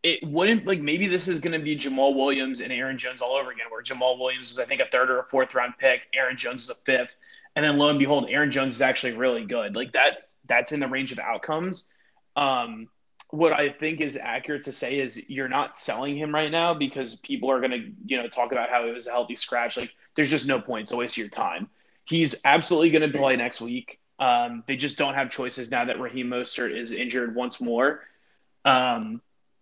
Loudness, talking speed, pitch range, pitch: -25 LUFS, 235 wpm, 125-160 Hz, 140 Hz